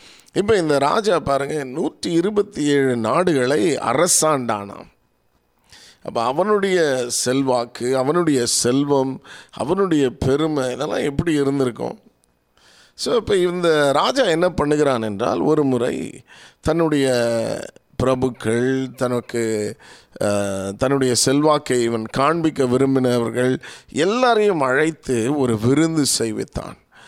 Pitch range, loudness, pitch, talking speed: 115-150 Hz, -19 LUFS, 130 Hz, 90 wpm